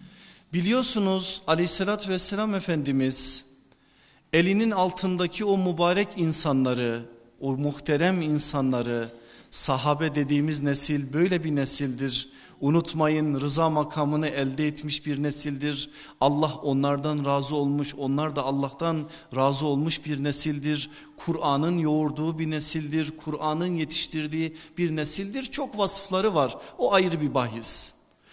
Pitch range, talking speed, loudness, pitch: 140-170 Hz, 110 wpm, -26 LUFS, 150 Hz